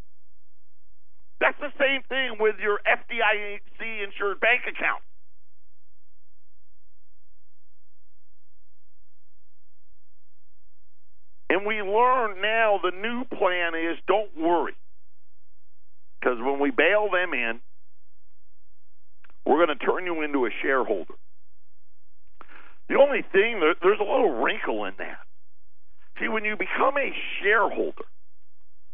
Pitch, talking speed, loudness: 80 Hz, 100 wpm, -24 LUFS